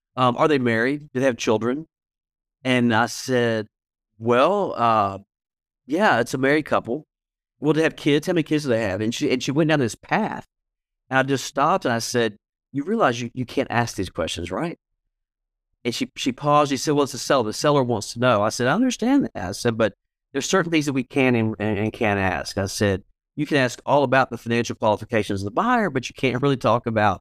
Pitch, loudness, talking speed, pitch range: 125 Hz, -22 LUFS, 230 wpm, 110-140 Hz